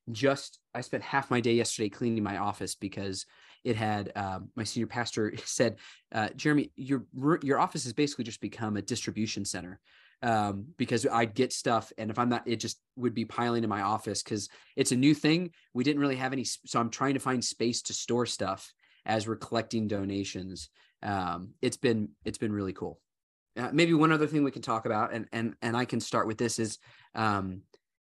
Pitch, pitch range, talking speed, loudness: 115 Hz, 105-125 Hz, 205 wpm, -31 LUFS